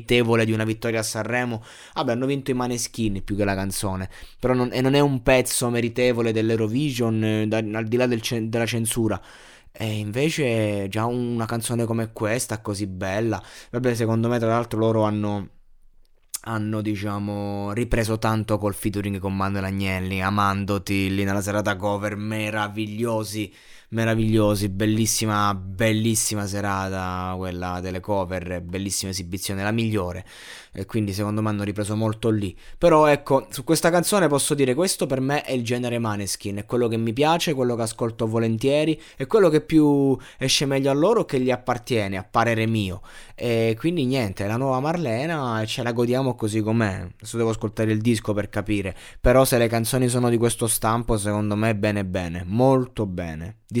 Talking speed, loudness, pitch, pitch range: 175 wpm, -23 LUFS, 110 Hz, 105-120 Hz